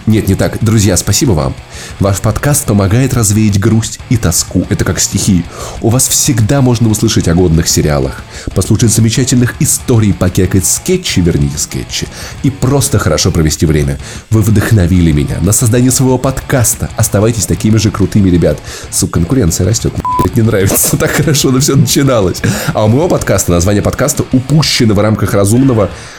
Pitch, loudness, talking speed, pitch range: 110 Hz, -10 LUFS, 160 wpm, 95-125 Hz